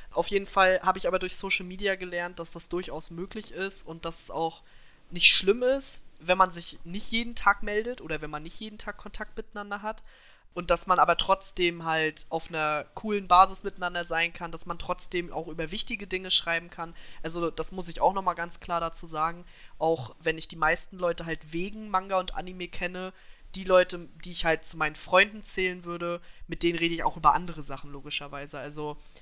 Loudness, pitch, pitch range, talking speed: -26 LUFS, 175 Hz, 165-190 Hz, 210 wpm